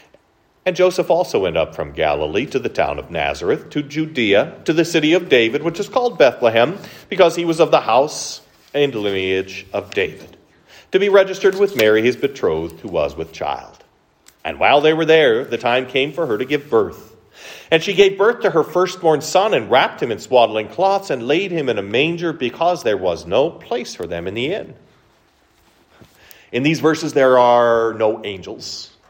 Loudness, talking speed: -17 LUFS, 195 wpm